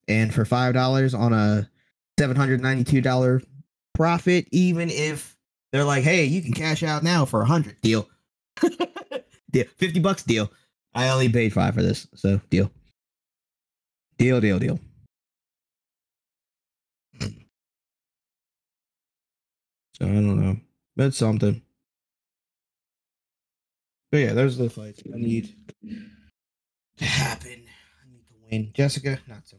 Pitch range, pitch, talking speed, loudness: 110-150 Hz, 125 Hz, 130 wpm, -23 LUFS